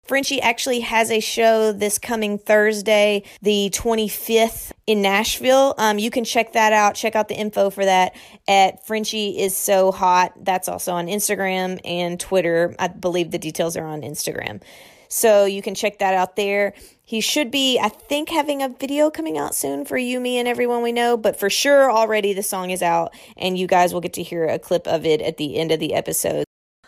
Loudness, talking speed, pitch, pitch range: -19 LUFS, 205 wpm, 205 Hz, 185-230 Hz